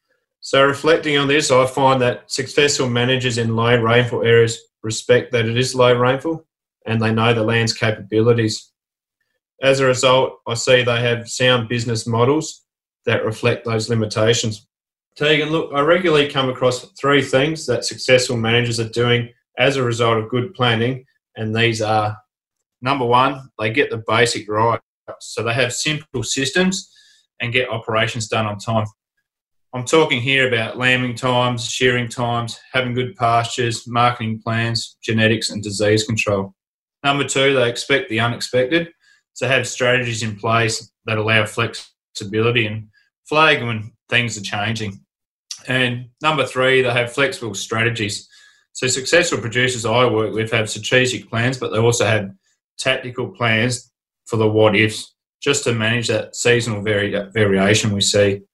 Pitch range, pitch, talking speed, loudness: 110-130 Hz, 120 Hz, 155 wpm, -18 LUFS